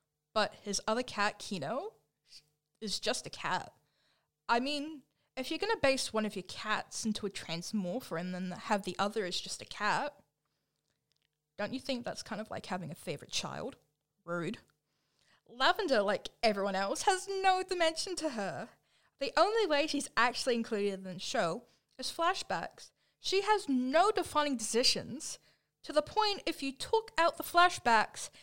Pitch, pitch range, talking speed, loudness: 240 Hz, 195-320 Hz, 165 wpm, -33 LUFS